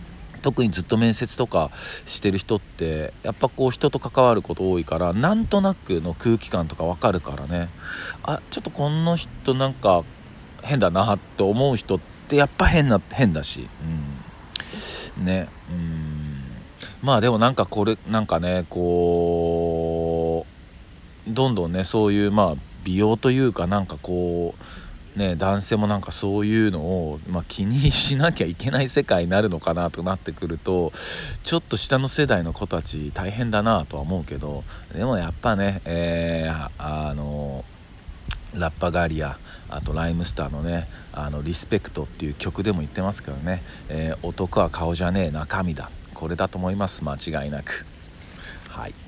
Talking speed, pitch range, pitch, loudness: 310 characters per minute, 80-105 Hz, 90 Hz, -23 LUFS